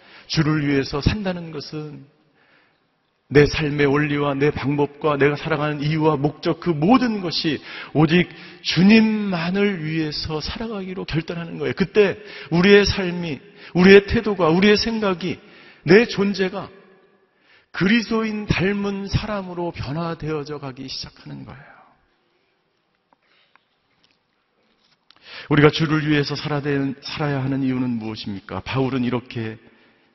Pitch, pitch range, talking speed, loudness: 155 Hz, 145-190 Hz, 265 characters per minute, -20 LUFS